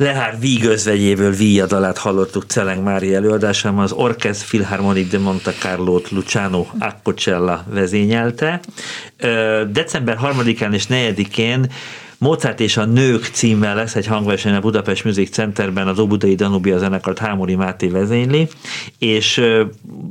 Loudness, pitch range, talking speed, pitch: -17 LUFS, 95-115 Hz, 120 wpm, 105 Hz